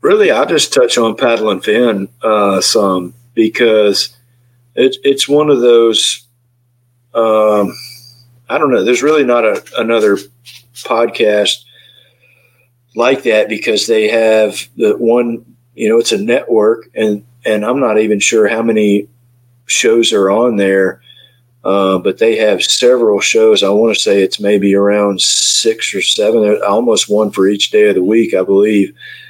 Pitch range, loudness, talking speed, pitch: 105-130 Hz, -11 LUFS, 155 wpm, 120 Hz